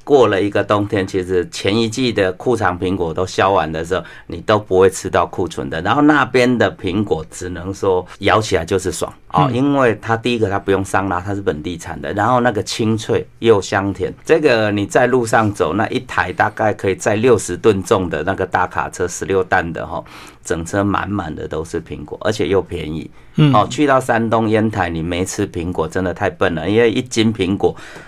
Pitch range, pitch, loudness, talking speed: 95-115 Hz, 100 Hz, -17 LUFS, 300 characters per minute